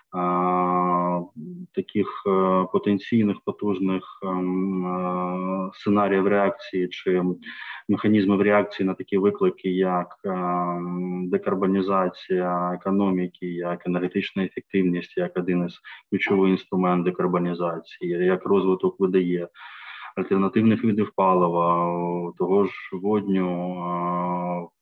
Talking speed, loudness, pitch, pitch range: 75 wpm, -24 LUFS, 95 Hz, 90-100 Hz